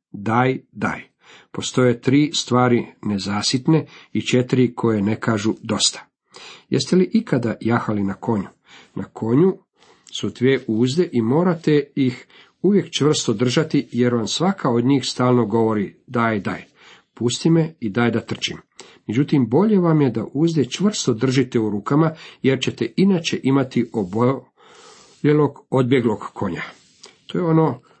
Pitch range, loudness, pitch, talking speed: 115-150 Hz, -20 LUFS, 130 Hz, 135 wpm